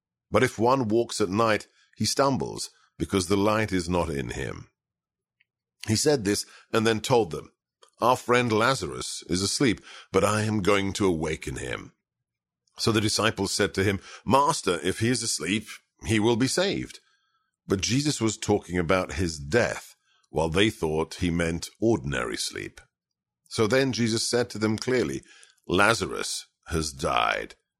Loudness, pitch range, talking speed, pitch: -26 LUFS, 90-115 Hz, 160 wpm, 105 Hz